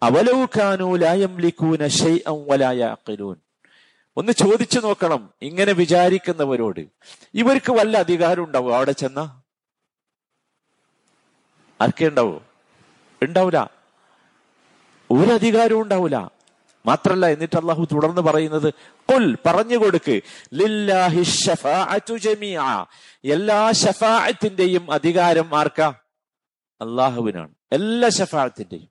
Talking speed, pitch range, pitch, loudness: 65 wpm, 150-210 Hz, 175 Hz, -19 LUFS